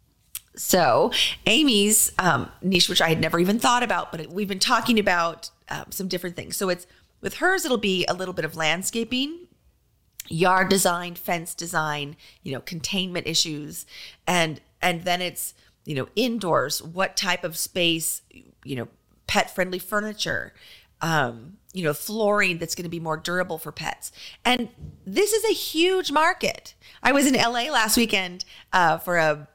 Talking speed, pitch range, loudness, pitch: 170 wpm, 165-220 Hz, -23 LUFS, 180 Hz